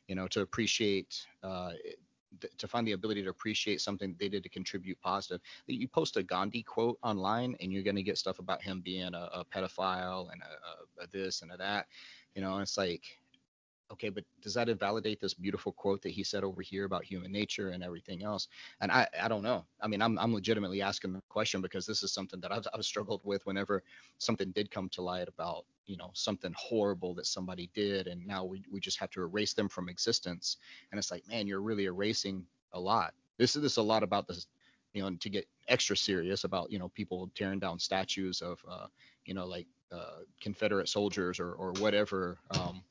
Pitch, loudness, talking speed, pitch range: 95 Hz, -35 LUFS, 220 wpm, 95-105 Hz